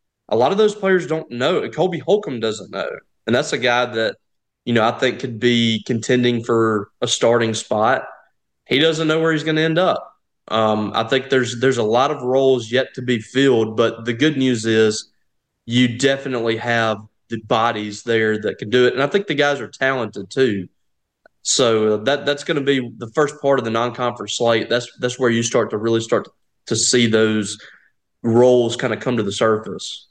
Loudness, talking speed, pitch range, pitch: -18 LUFS, 205 wpm, 115-135 Hz, 120 Hz